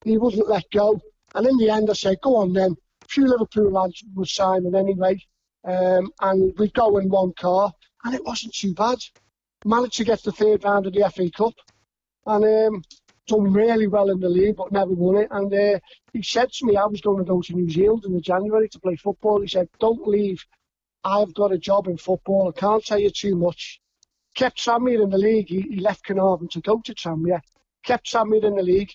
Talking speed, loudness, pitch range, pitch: 225 wpm, -21 LUFS, 185-220 Hz, 200 Hz